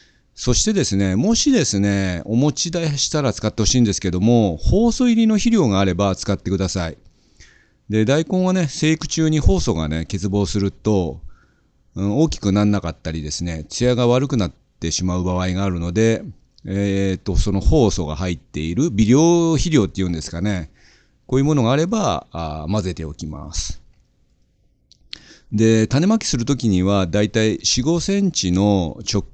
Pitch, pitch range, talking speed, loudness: 105 Hz, 90-140 Hz, 335 characters per minute, -19 LUFS